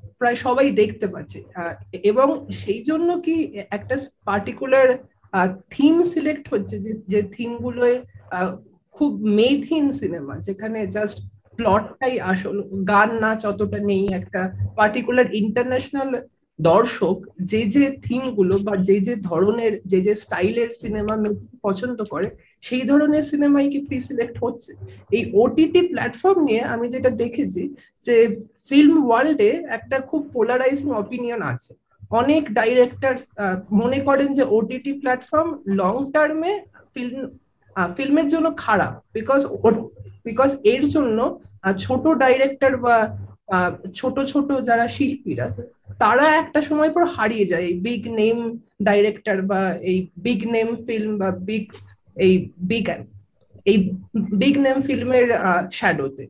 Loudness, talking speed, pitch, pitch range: -20 LUFS, 120 wpm, 230 Hz, 200-270 Hz